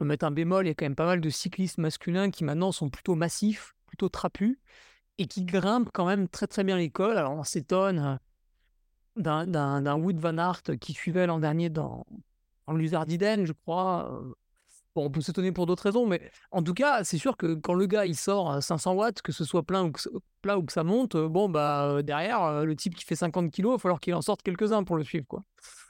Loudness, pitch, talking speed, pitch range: -28 LUFS, 175 Hz, 230 wpm, 160-195 Hz